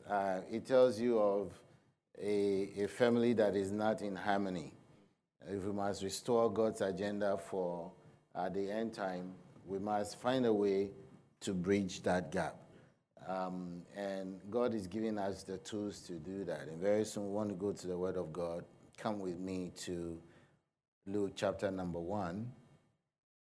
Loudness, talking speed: -37 LUFS, 165 wpm